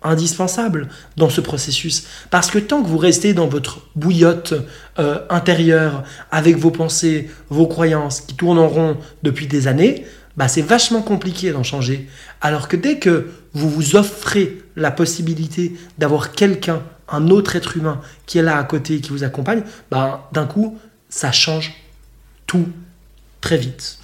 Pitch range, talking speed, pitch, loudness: 150-175 Hz, 160 wpm, 160 Hz, -17 LUFS